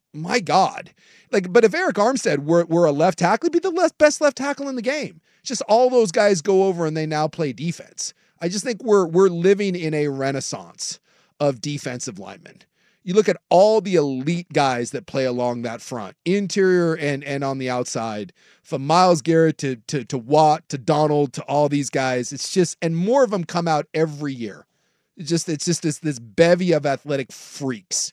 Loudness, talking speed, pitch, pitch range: -20 LUFS, 205 wpm, 160 Hz, 140-190 Hz